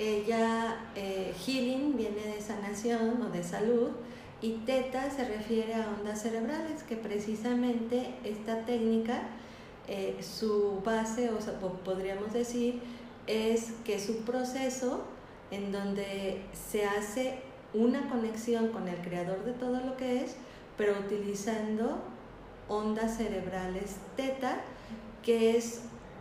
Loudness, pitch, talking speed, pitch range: -33 LUFS, 225 Hz, 120 wpm, 205-245 Hz